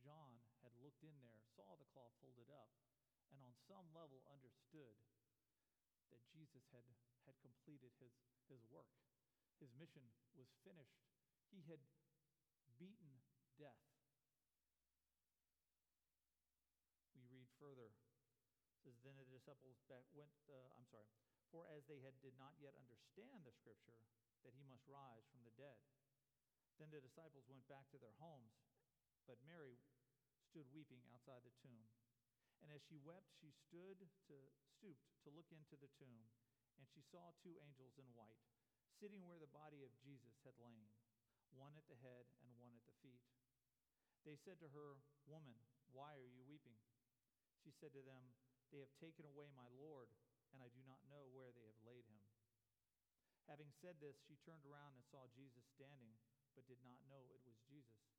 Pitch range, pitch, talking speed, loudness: 120-145 Hz, 130 Hz, 160 wpm, -67 LUFS